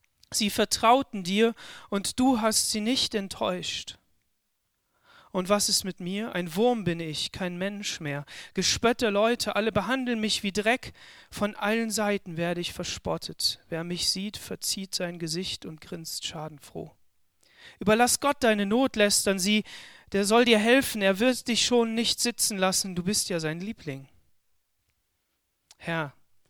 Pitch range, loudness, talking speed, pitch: 175-225 Hz, -26 LUFS, 150 wpm, 205 Hz